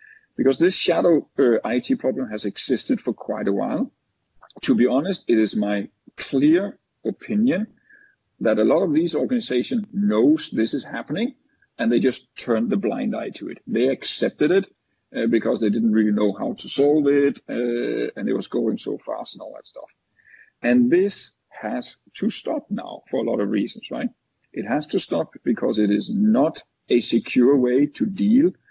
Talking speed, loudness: 185 wpm, -22 LUFS